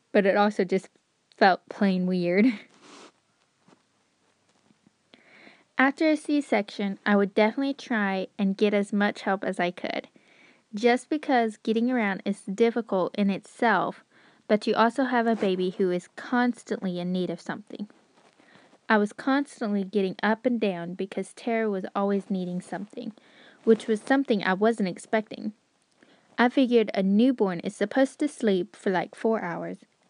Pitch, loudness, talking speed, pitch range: 215 Hz, -26 LUFS, 150 wpm, 195-240 Hz